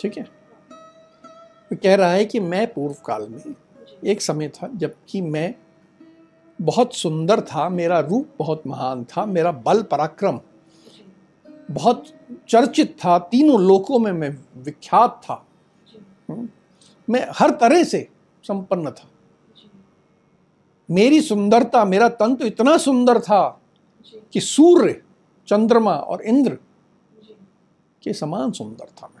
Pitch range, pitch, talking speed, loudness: 175-245 Hz, 210 Hz, 125 wpm, -18 LUFS